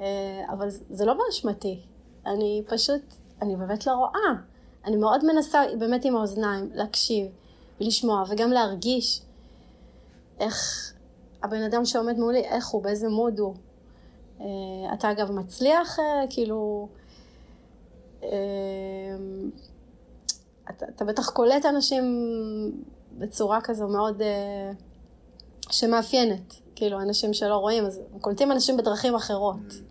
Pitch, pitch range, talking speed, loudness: 210 Hz, 195-235 Hz, 105 wpm, -26 LUFS